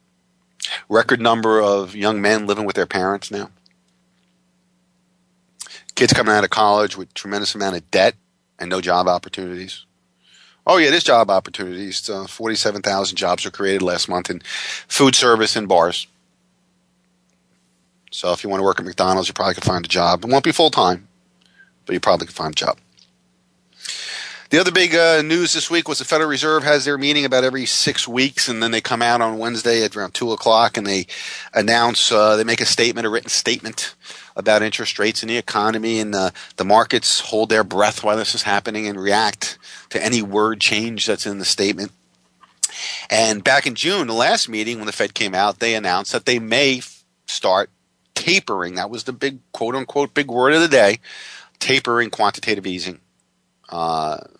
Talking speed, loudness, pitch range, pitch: 190 wpm, -18 LUFS, 90-115 Hz, 105 Hz